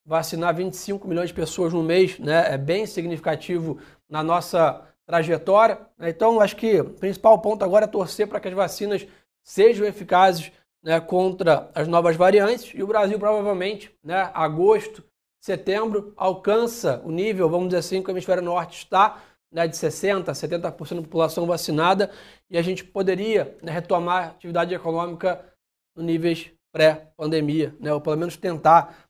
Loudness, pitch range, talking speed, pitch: -22 LUFS, 165-200 Hz, 155 wpm, 180 Hz